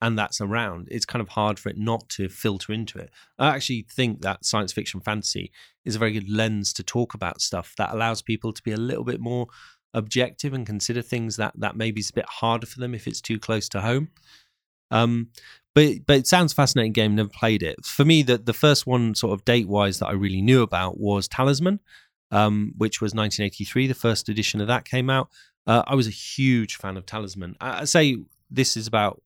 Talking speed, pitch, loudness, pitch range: 225 wpm, 115 Hz, -23 LUFS, 105-125 Hz